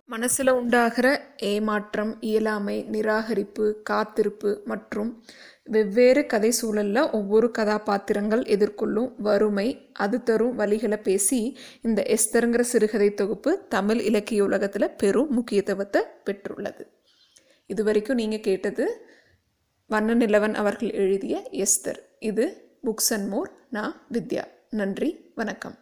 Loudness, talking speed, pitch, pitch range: -24 LUFS, 105 wpm, 220 Hz, 210-245 Hz